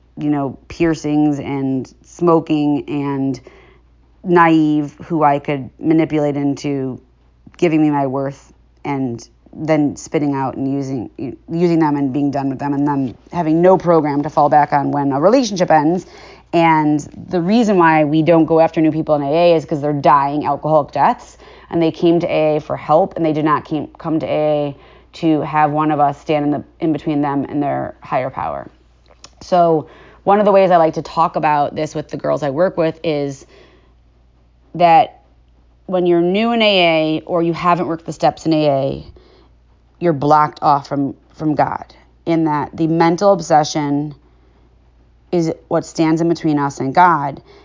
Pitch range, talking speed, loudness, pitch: 140-165 Hz, 180 wpm, -16 LUFS, 150 Hz